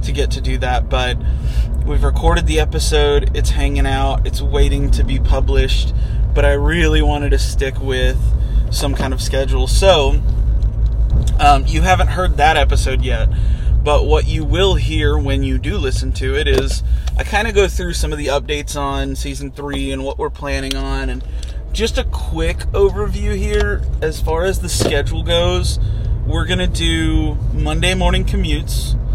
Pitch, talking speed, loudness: 80 Hz, 175 wpm, -17 LUFS